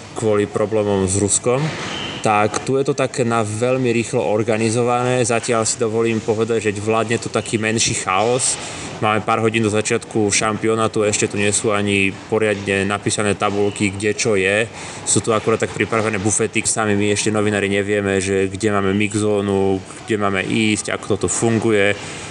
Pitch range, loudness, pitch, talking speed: 105-115 Hz, -18 LUFS, 110 Hz, 165 wpm